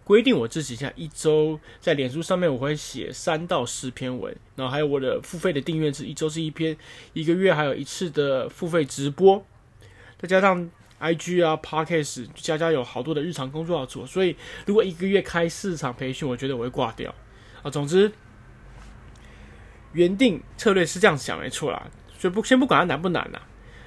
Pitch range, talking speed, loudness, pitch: 130-180 Hz, 295 characters per minute, -24 LUFS, 155 Hz